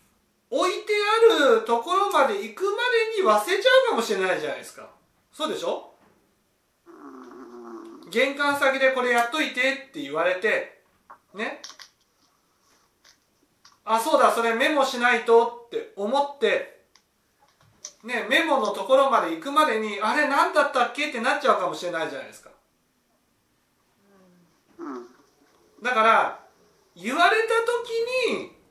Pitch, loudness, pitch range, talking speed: 285 Hz, -22 LUFS, 240-400 Hz, 265 characters per minute